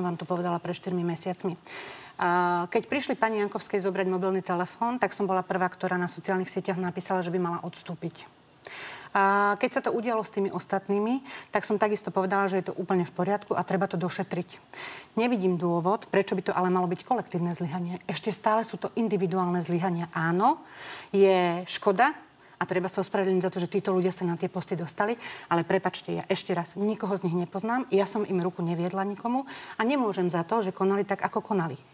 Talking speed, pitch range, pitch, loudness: 195 wpm, 180-205 Hz, 190 Hz, -28 LUFS